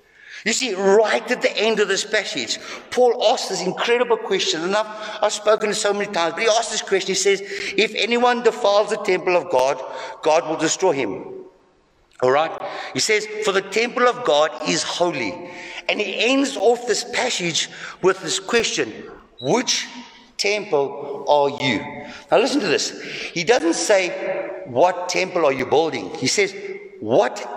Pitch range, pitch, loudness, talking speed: 180-245 Hz, 215 Hz, -20 LUFS, 170 wpm